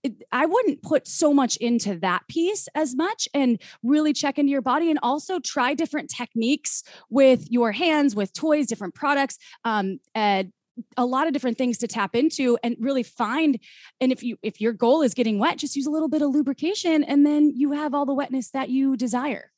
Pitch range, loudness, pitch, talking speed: 240-295 Hz, -23 LUFS, 270 Hz, 205 wpm